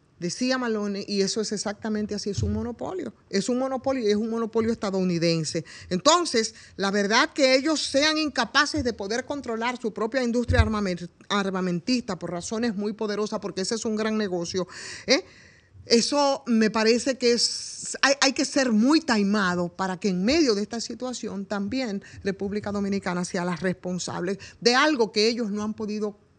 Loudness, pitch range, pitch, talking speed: -25 LUFS, 195-245 Hz, 215 Hz, 165 wpm